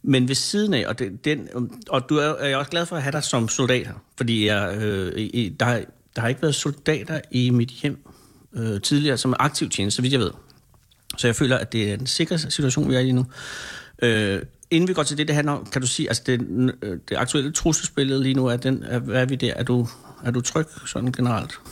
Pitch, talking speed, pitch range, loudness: 130 Hz, 250 wpm, 120-145 Hz, -23 LUFS